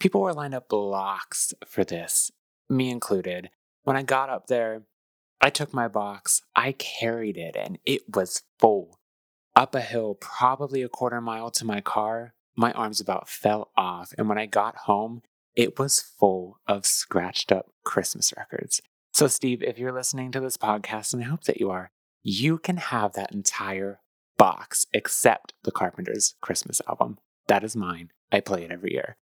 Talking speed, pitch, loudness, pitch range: 175 wpm, 115 Hz, -25 LUFS, 100-130 Hz